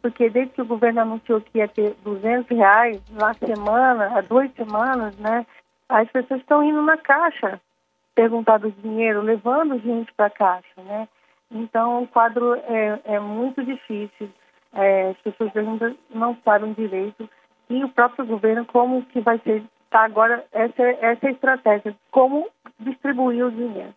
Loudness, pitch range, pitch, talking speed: -20 LUFS, 215-245 Hz, 230 Hz, 155 wpm